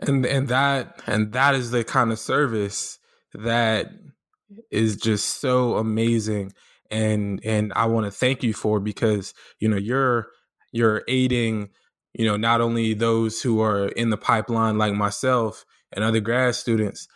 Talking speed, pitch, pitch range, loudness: 160 wpm, 115 Hz, 105-125 Hz, -23 LUFS